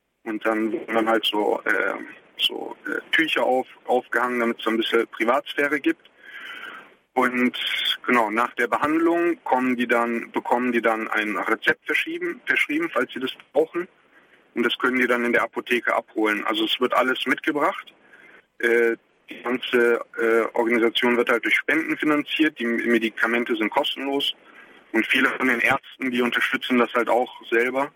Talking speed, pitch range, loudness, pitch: 165 wpm, 115-140 Hz, -22 LUFS, 120 Hz